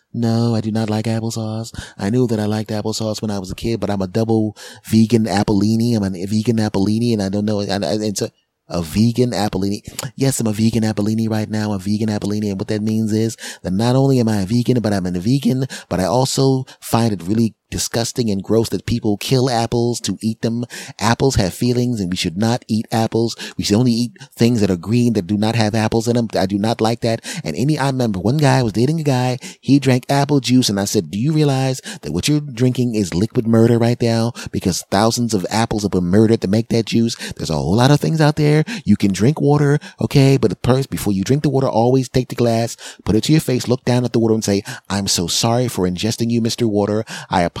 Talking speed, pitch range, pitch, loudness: 245 wpm, 105-125 Hz, 115 Hz, -18 LUFS